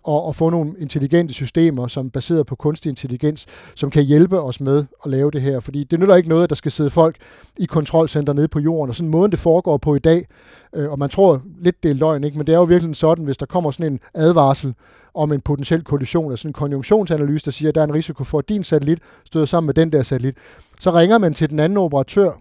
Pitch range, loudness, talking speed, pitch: 145-165 Hz, -17 LUFS, 255 wpm, 155 Hz